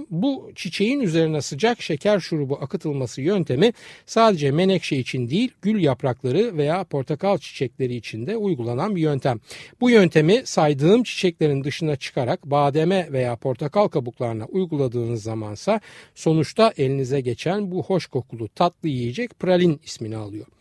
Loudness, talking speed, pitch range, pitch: -22 LUFS, 130 wpm, 135-190 Hz, 155 Hz